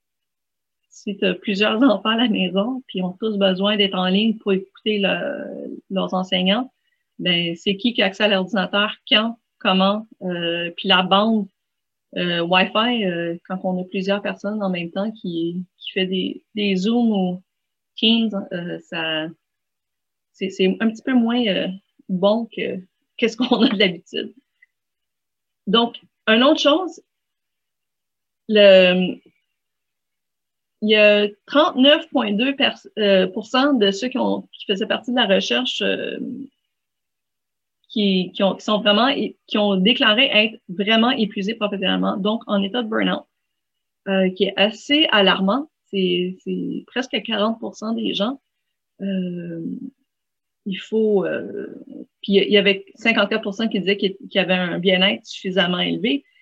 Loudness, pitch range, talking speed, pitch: -19 LUFS, 190-235 Hz, 140 wpm, 205 Hz